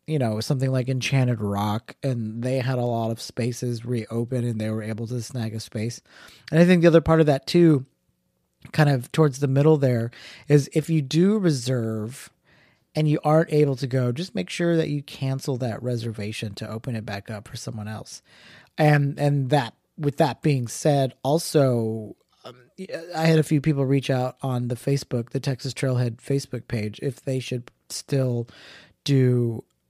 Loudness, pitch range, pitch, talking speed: -23 LUFS, 115-145 Hz, 130 Hz, 185 wpm